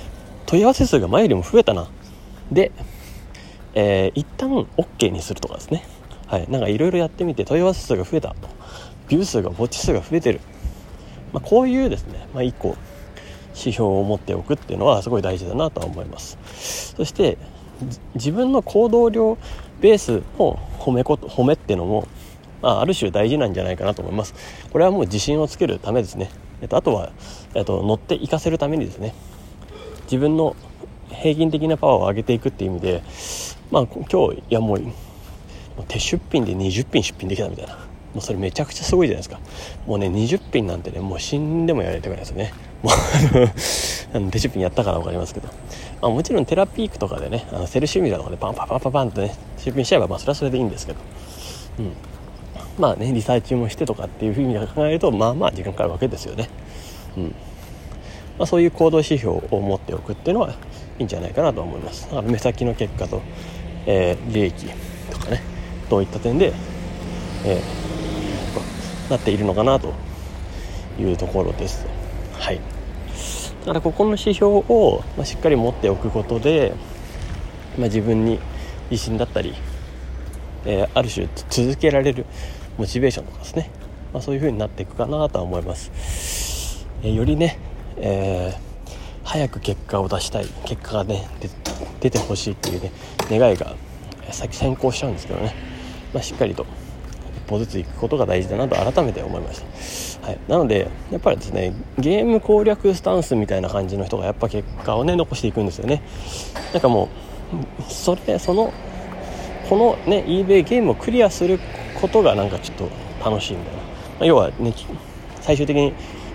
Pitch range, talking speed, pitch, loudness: 90-130 Hz, 370 characters per minute, 105 Hz, -21 LUFS